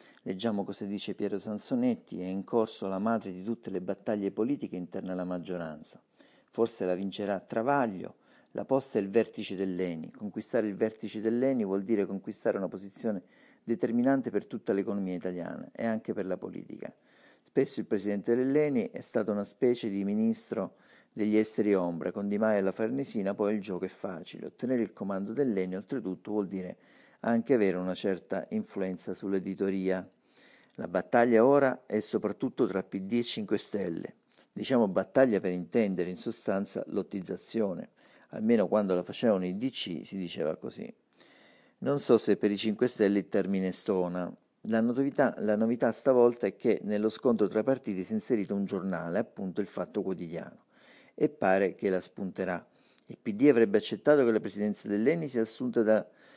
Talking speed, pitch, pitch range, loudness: 165 wpm, 105 Hz, 95-115 Hz, -31 LUFS